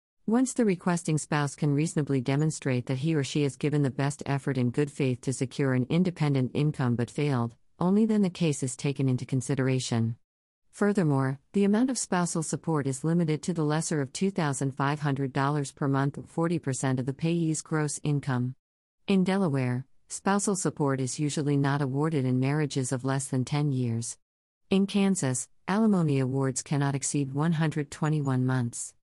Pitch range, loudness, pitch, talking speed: 135-160 Hz, -28 LUFS, 145 Hz, 165 wpm